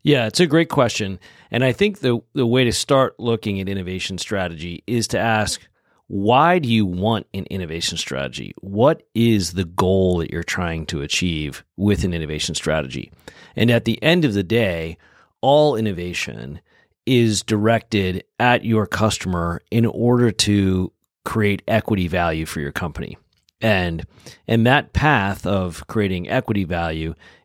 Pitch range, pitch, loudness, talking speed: 90-115 Hz, 100 Hz, -20 LUFS, 155 wpm